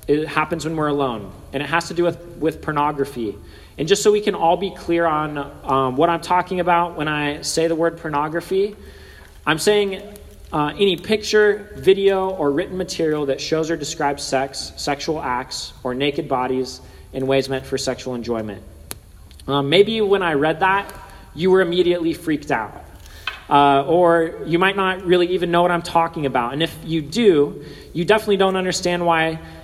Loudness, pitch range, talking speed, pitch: -19 LUFS, 140-180 Hz, 180 wpm, 160 Hz